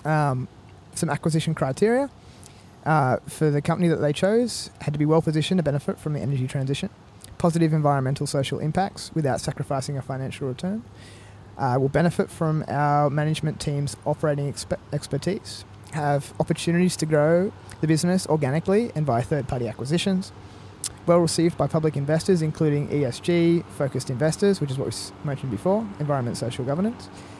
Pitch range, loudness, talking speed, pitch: 135-165 Hz, -24 LUFS, 150 wpm, 150 Hz